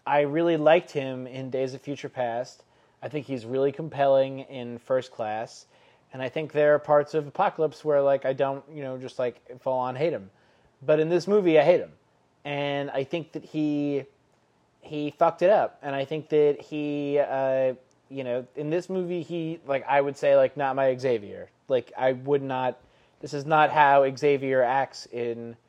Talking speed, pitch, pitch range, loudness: 195 wpm, 140 Hz, 130-150 Hz, -26 LUFS